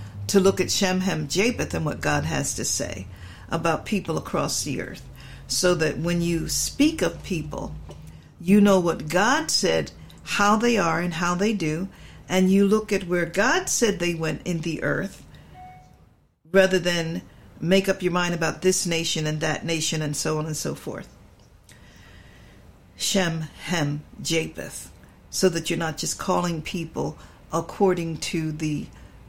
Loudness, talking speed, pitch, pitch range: -24 LUFS, 160 wpm, 170 Hz, 155-190 Hz